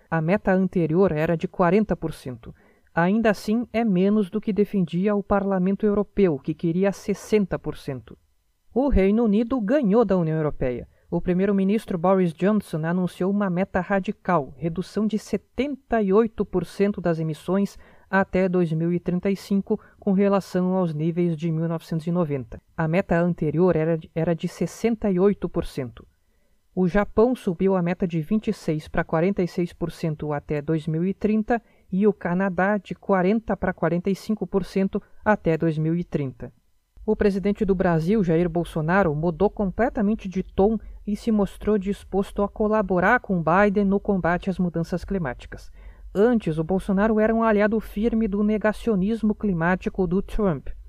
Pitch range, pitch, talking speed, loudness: 170-210 Hz, 190 Hz, 130 wpm, -23 LUFS